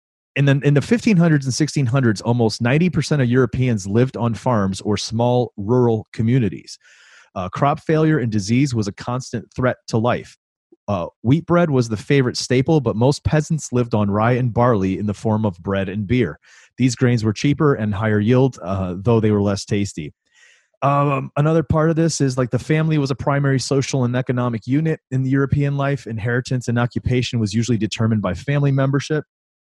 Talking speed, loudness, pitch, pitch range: 190 wpm, -19 LUFS, 125 Hz, 110-140 Hz